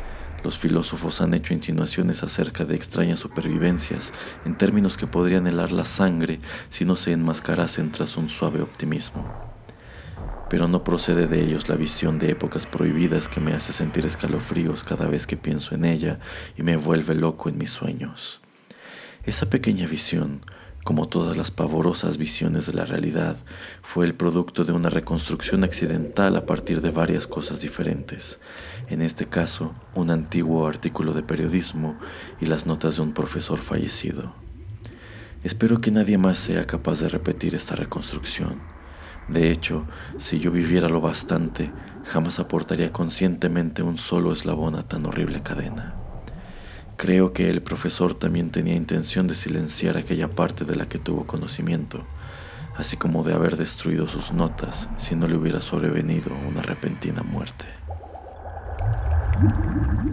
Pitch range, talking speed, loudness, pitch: 80-90 Hz, 150 wpm, -24 LUFS, 85 Hz